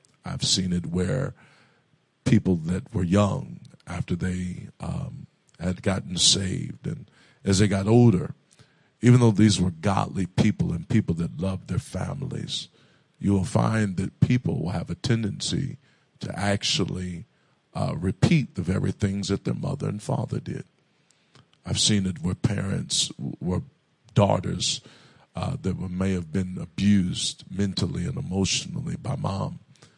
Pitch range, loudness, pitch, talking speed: 90-110 Hz, -25 LUFS, 100 Hz, 145 wpm